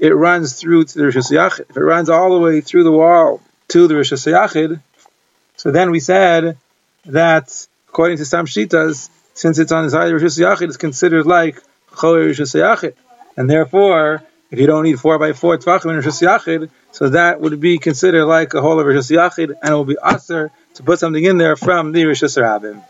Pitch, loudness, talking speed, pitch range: 160 Hz, -13 LUFS, 195 wpm, 155-170 Hz